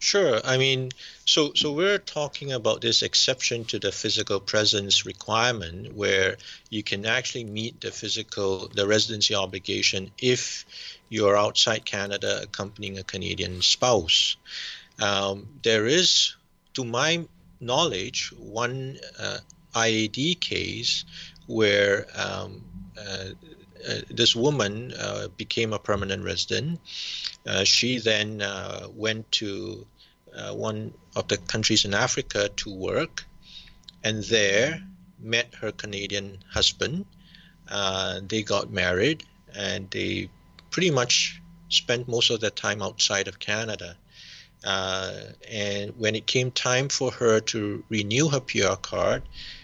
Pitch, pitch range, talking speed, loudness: 110 Hz, 100-125 Hz, 125 wpm, -24 LUFS